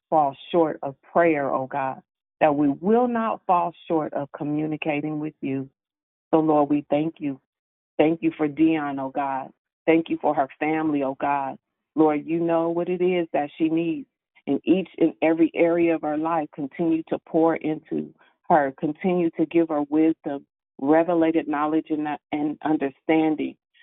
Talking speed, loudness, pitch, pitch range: 170 wpm, -24 LUFS, 155 Hz, 145-165 Hz